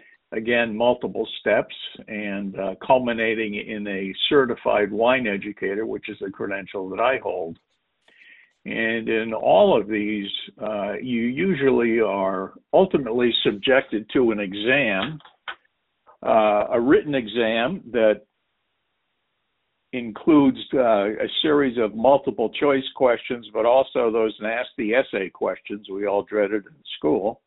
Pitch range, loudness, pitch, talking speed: 105-120 Hz, -22 LUFS, 110 Hz, 120 wpm